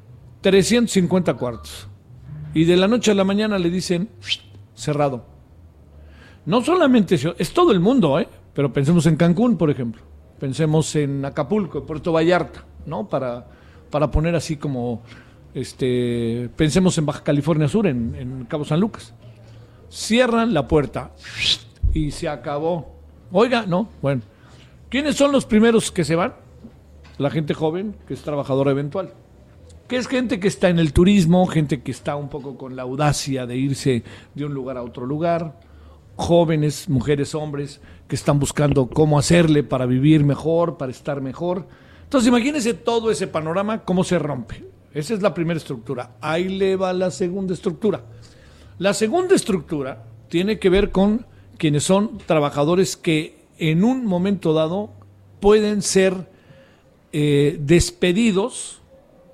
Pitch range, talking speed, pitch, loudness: 130-190 Hz, 150 wpm, 155 Hz, -20 LUFS